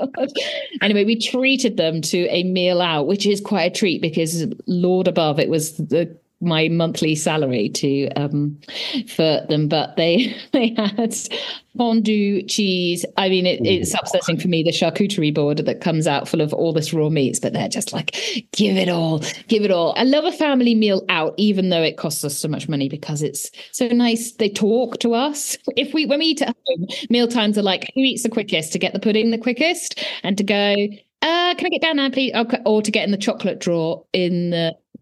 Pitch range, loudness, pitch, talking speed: 165-235 Hz, -19 LUFS, 200 Hz, 210 wpm